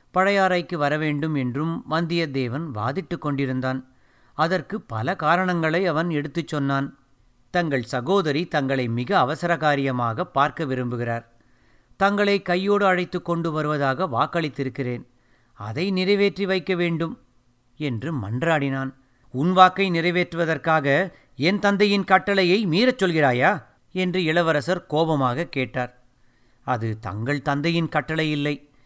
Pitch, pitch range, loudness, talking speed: 155 Hz, 130-180 Hz, -23 LUFS, 100 wpm